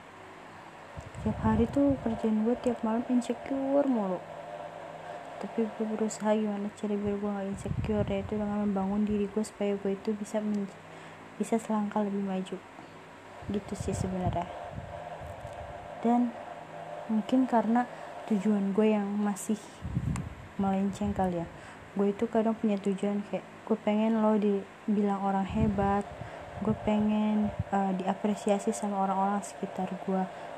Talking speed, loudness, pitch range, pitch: 130 wpm, -30 LUFS, 195-220 Hz, 210 Hz